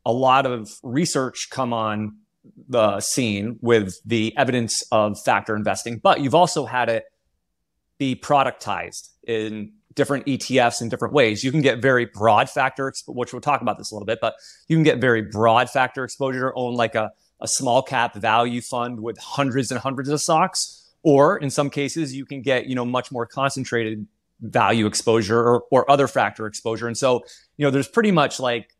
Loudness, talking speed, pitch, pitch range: -21 LUFS, 190 wpm, 125 Hz, 115-135 Hz